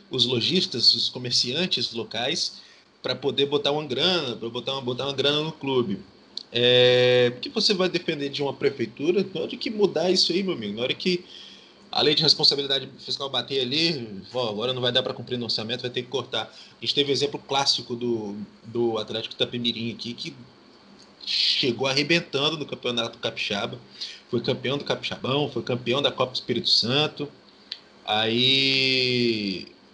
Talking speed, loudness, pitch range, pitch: 175 wpm, -23 LUFS, 120-145 Hz, 130 Hz